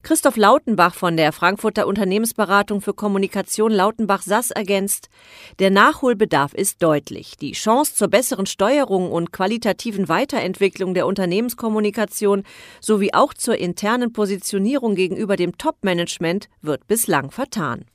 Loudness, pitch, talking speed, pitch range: -19 LUFS, 200 Hz, 120 wpm, 185-220 Hz